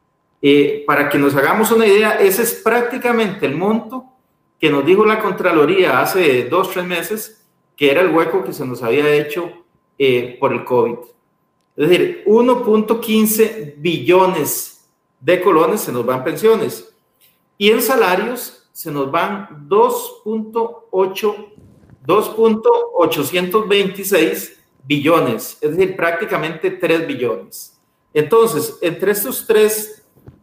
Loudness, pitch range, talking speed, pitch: -16 LUFS, 165-225 Hz, 120 wpm, 205 Hz